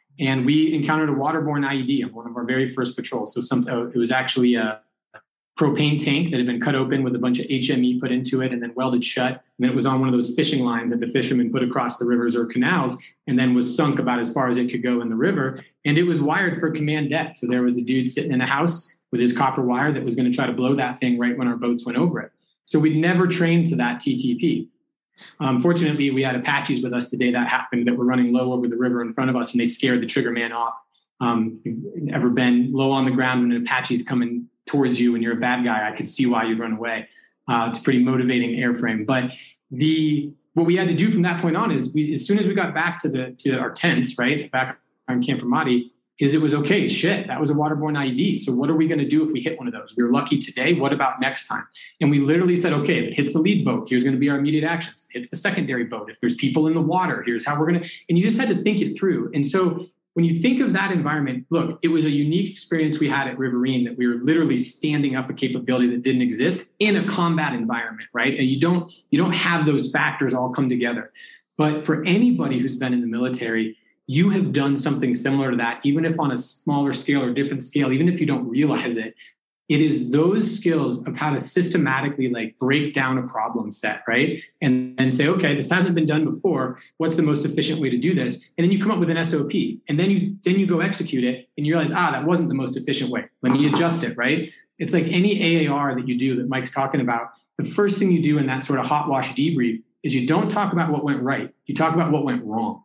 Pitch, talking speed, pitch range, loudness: 135 Hz, 265 wpm, 125-160 Hz, -21 LUFS